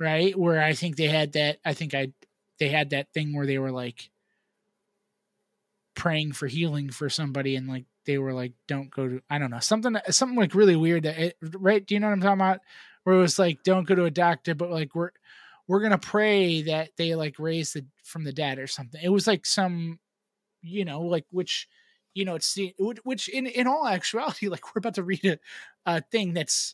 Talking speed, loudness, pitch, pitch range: 225 wpm, -26 LUFS, 170 Hz, 150-200 Hz